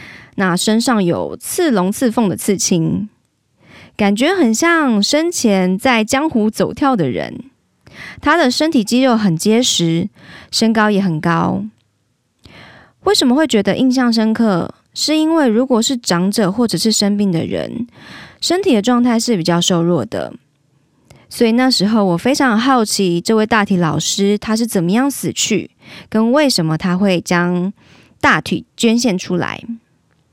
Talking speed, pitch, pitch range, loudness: 220 characters per minute, 220 Hz, 185-250 Hz, -15 LUFS